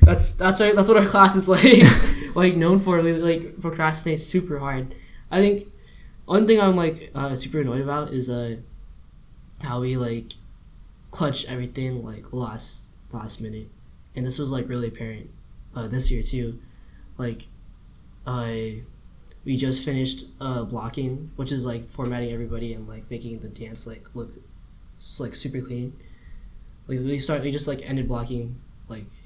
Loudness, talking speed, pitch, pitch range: -22 LUFS, 165 wpm, 125 Hz, 115-145 Hz